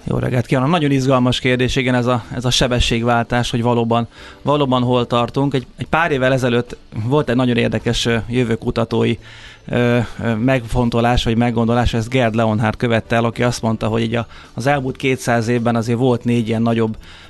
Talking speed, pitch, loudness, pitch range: 180 wpm, 120 Hz, -17 LUFS, 115-125 Hz